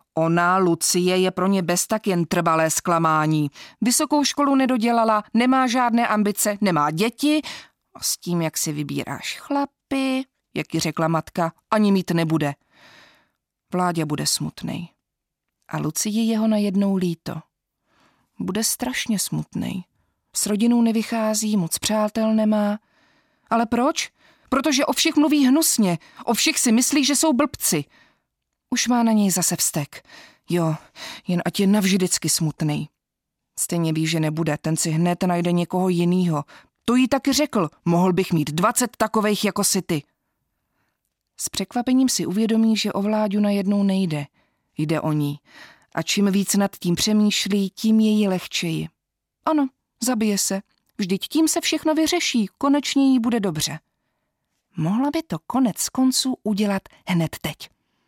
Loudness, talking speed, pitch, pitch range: -21 LUFS, 145 wpm, 205 Hz, 170-245 Hz